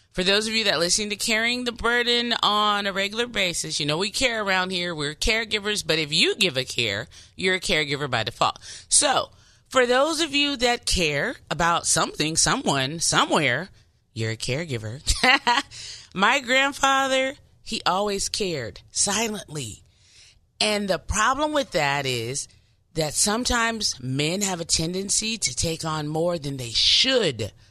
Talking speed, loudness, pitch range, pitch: 155 wpm, -22 LUFS, 135-225 Hz, 185 Hz